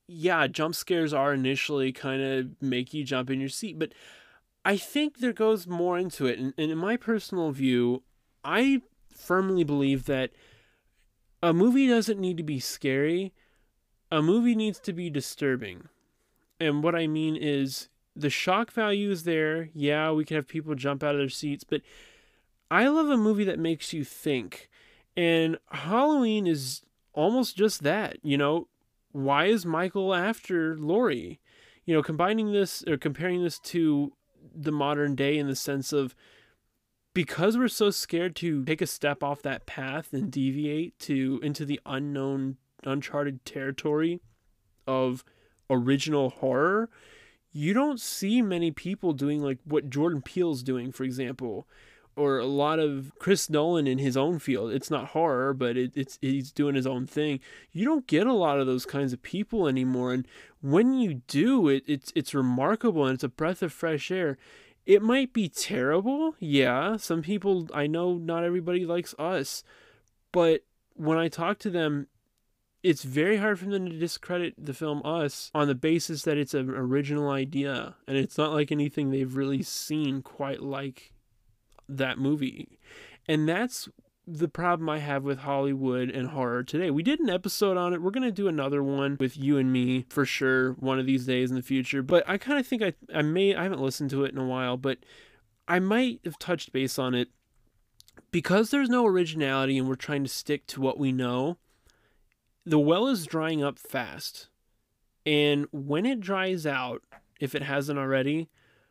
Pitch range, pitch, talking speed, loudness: 135-175 Hz, 150 Hz, 175 wpm, -28 LUFS